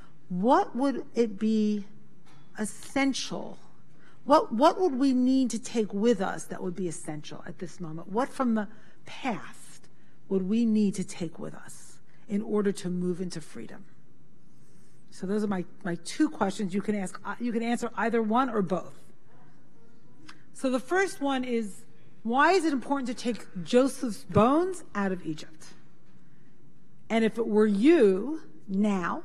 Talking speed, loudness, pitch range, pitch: 160 wpm, -28 LUFS, 185-250 Hz, 215 Hz